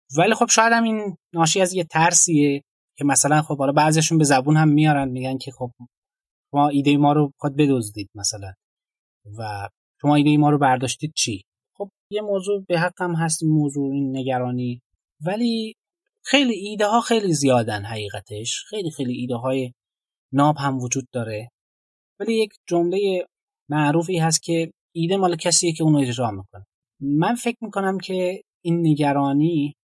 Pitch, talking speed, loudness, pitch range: 150 Hz, 160 wpm, -20 LUFS, 130-180 Hz